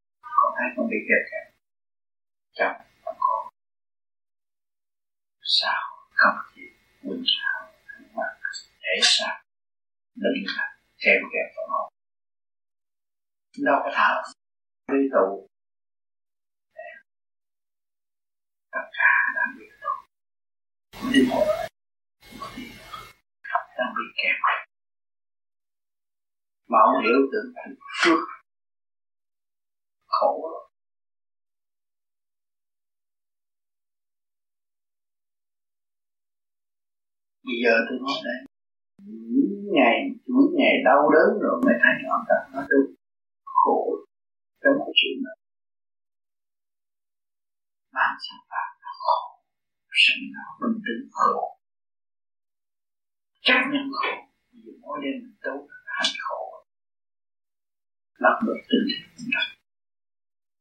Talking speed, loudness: 70 wpm, -23 LUFS